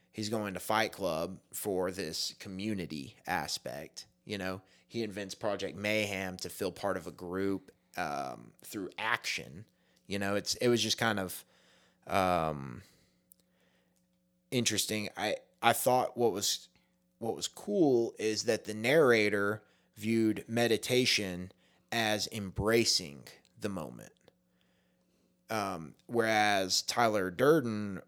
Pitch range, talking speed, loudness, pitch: 90-110 Hz, 120 wpm, -32 LUFS, 100 Hz